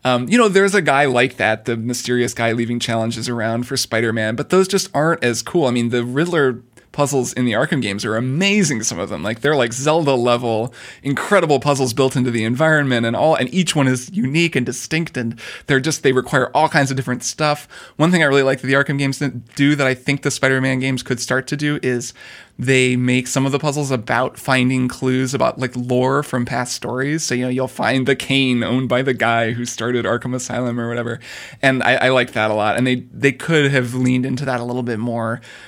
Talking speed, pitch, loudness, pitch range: 235 wpm, 130 Hz, -18 LUFS, 120-140 Hz